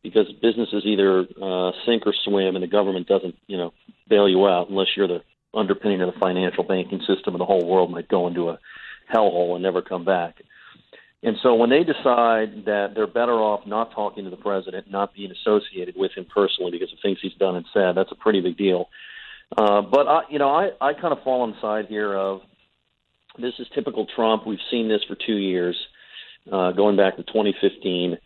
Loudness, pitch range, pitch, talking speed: -22 LUFS, 95-110 Hz, 100 Hz, 210 wpm